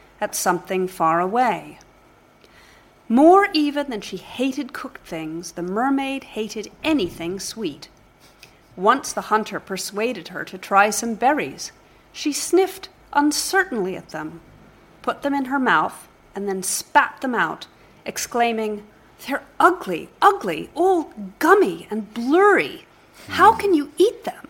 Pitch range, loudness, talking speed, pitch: 195-305 Hz, -21 LUFS, 130 wpm, 235 Hz